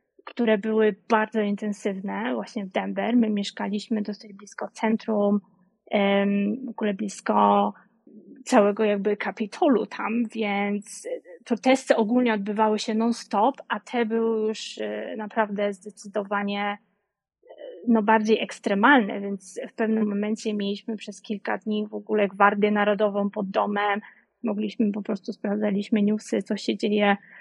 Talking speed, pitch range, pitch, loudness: 125 wpm, 205-225 Hz, 210 Hz, -25 LUFS